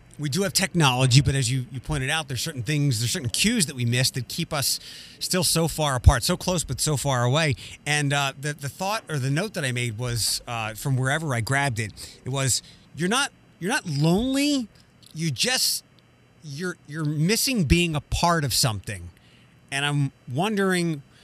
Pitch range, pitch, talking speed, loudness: 130-165 Hz, 145 Hz, 200 wpm, -24 LUFS